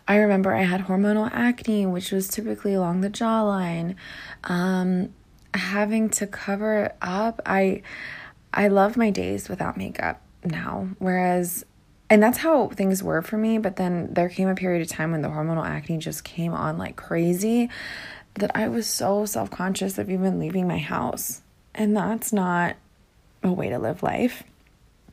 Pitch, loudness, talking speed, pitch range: 195 Hz, -24 LUFS, 165 wpm, 180-215 Hz